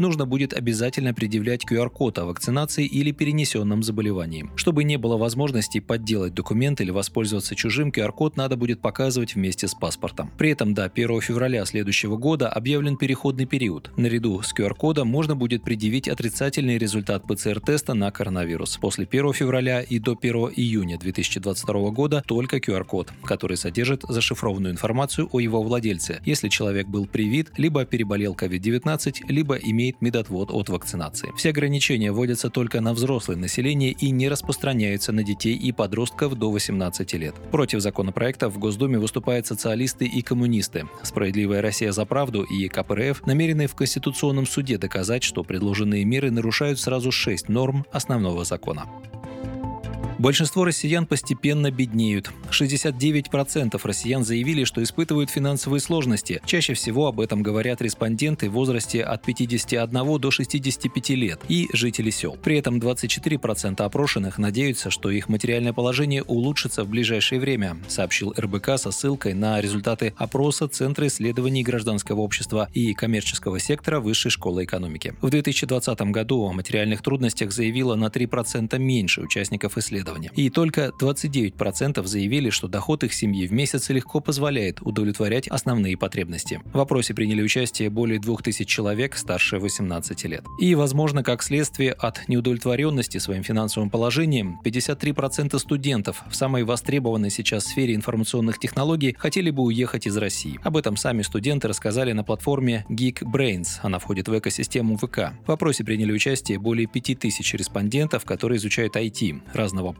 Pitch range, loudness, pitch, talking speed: 105-135 Hz, -23 LUFS, 120 Hz, 145 wpm